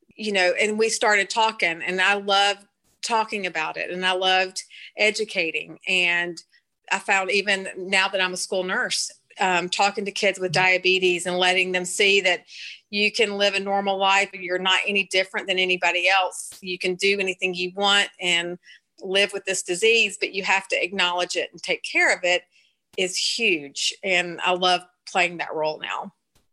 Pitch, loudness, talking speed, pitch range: 190 Hz, -21 LUFS, 185 wpm, 180-200 Hz